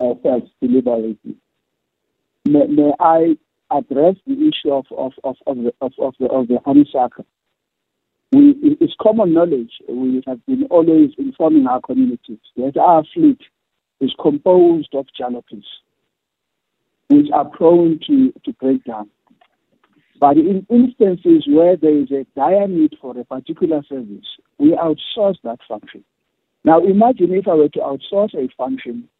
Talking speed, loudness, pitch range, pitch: 140 wpm, -15 LUFS, 130-190 Hz, 155 Hz